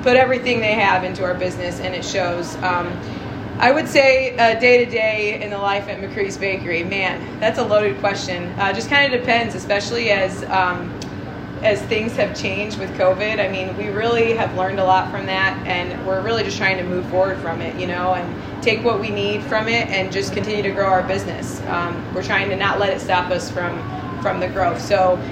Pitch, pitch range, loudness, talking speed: 210 Hz, 190-235 Hz, -19 LUFS, 220 wpm